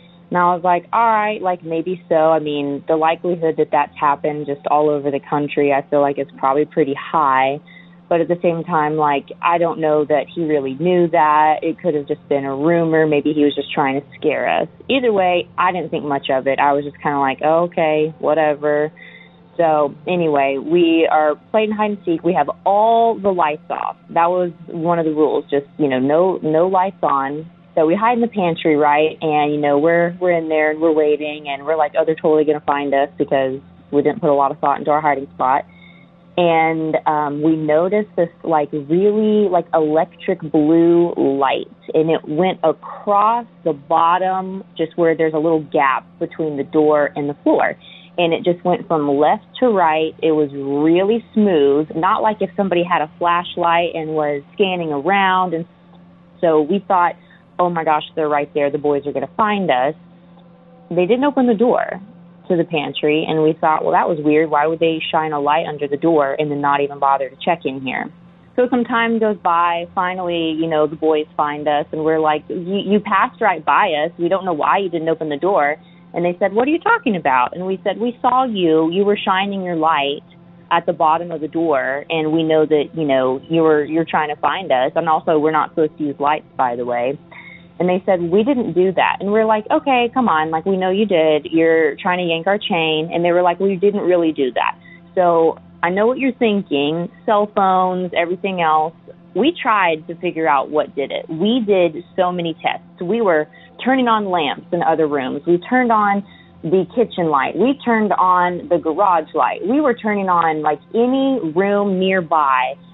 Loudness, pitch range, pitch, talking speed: -17 LUFS, 150-185 Hz, 165 Hz, 215 wpm